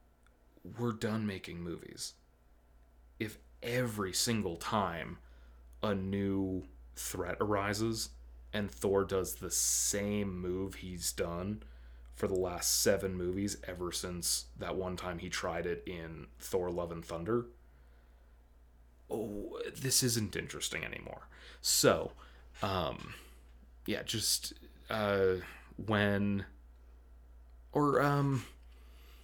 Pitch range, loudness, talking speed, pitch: 60-100 Hz, -35 LUFS, 105 wpm, 85 Hz